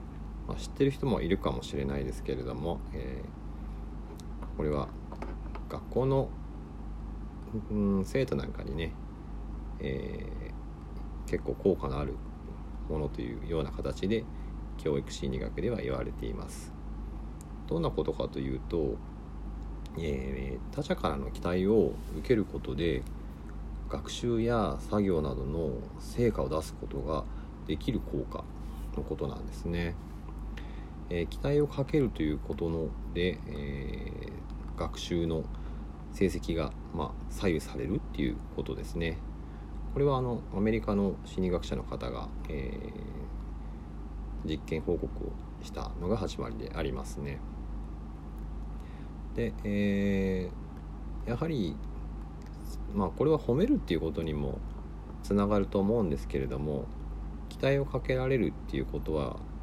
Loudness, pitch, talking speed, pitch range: -34 LUFS, 75 Hz, 240 characters per minute, 75-85 Hz